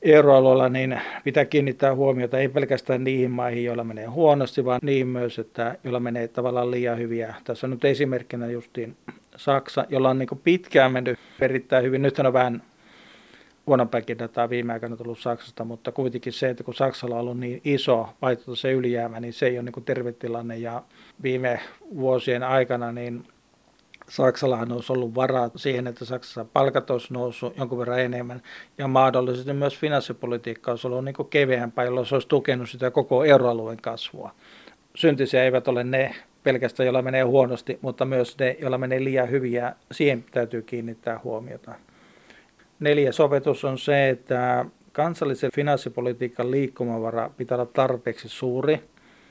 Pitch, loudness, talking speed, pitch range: 125 Hz, -24 LUFS, 155 wpm, 120-135 Hz